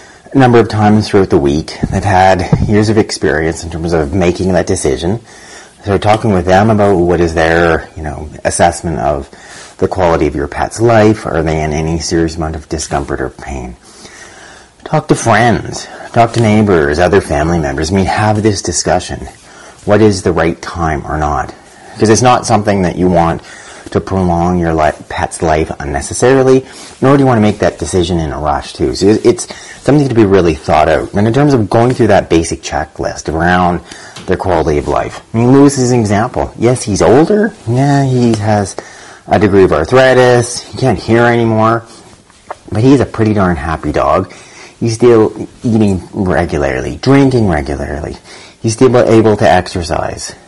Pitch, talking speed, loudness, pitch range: 100 Hz, 185 wpm, -11 LUFS, 85-115 Hz